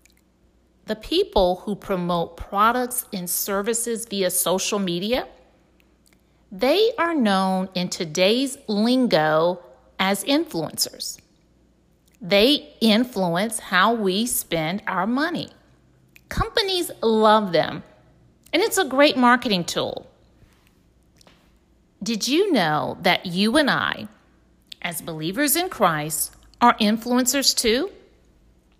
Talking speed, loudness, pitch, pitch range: 100 wpm, -21 LUFS, 210 Hz, 180-255 Hz